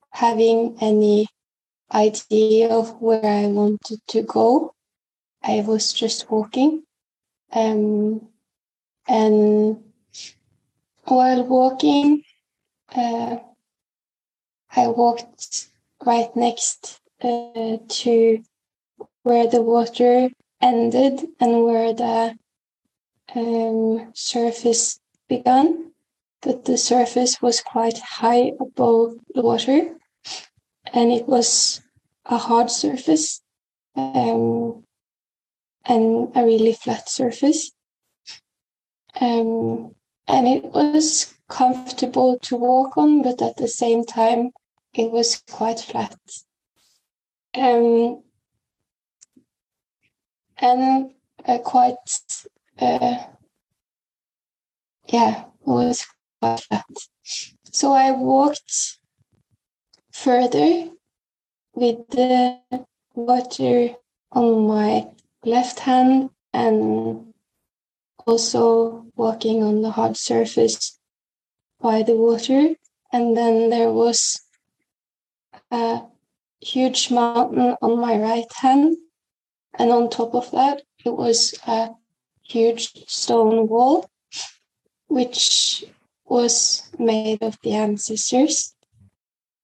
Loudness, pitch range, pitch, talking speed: -19 LUFS, 225-255 Hz, 235 Hz, 90 wpm